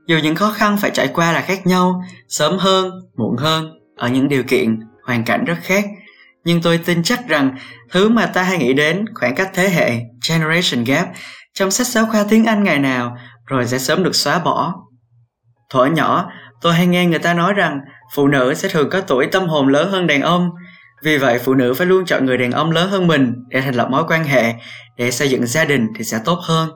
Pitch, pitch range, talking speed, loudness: 160 Hz, 125-185 Hz, 230 wpm, -16 LUFS